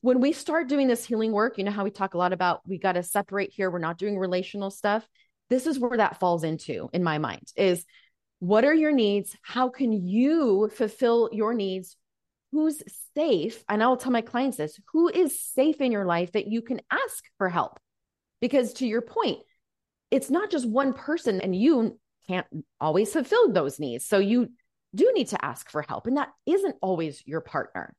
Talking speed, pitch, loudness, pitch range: 205 wpm, 220 Hz, -26 LUFS, 185-265 Hz